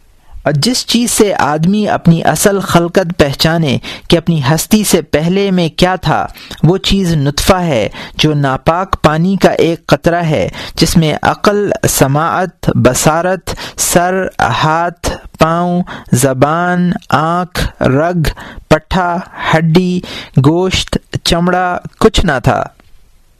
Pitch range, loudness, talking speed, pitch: 155-185 Hz, -12 LUFS, 120 wpm, 170 Hz